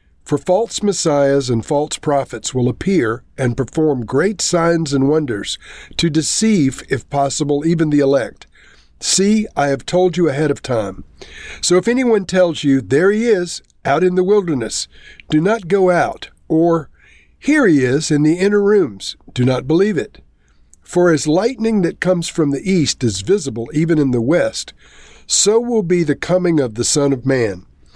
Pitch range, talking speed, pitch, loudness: 135-185 Hz, 175 wpm, 155 Hz, -16 LUFS